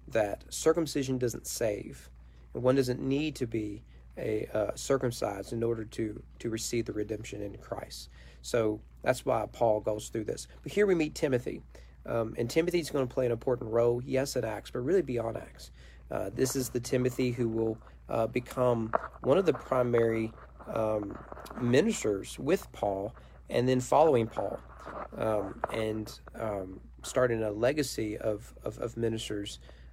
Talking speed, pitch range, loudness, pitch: 160 wpm, 105-125 Hz, -31 LUFS, 115 Hz